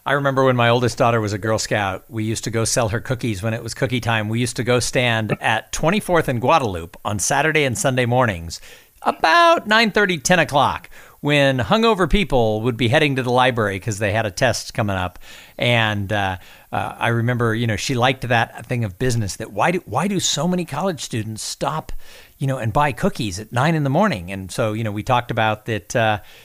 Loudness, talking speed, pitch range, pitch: -19 LUFS, 225 wpm, 110-140 Hz, 120 Hz